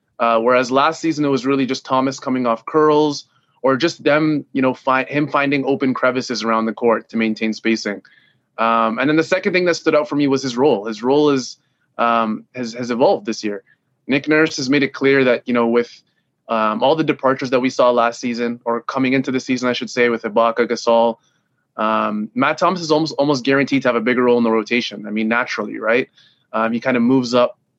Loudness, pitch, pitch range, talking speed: -17 LUFS, 130 Hz, 115-140 Hz, 230 wpm